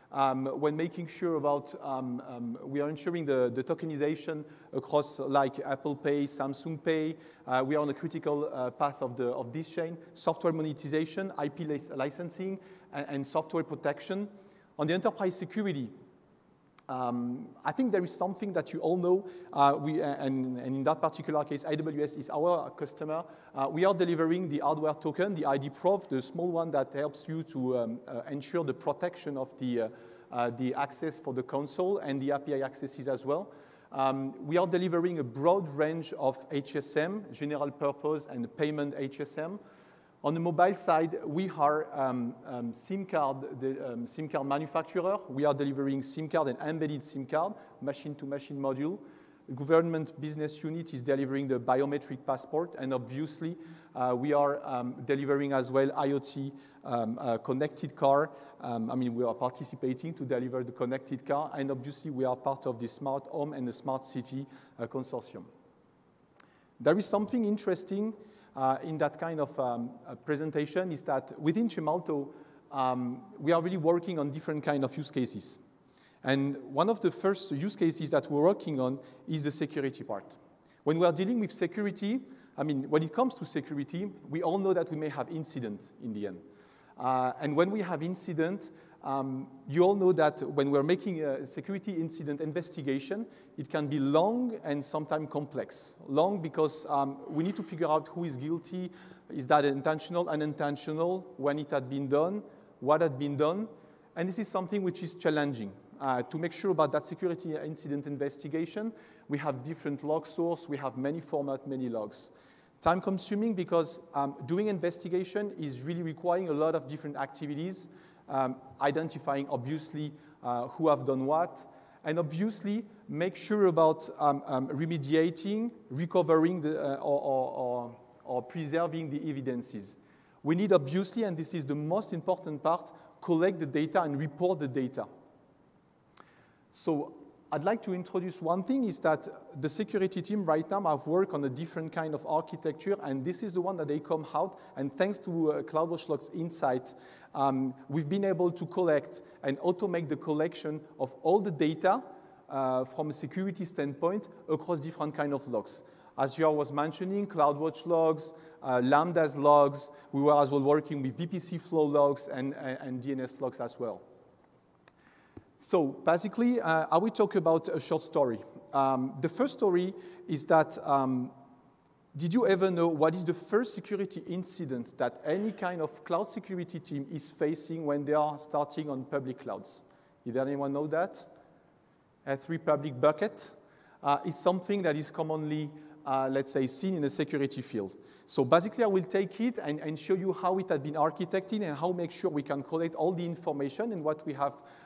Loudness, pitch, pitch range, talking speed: -32 LUFS, 155 Hz, 140-175 Hz, 175 wpm